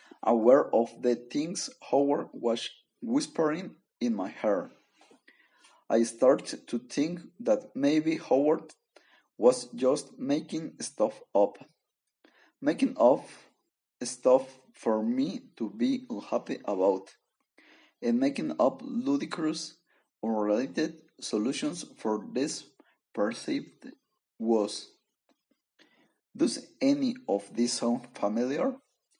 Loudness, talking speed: -29 LUFS, 95 wpm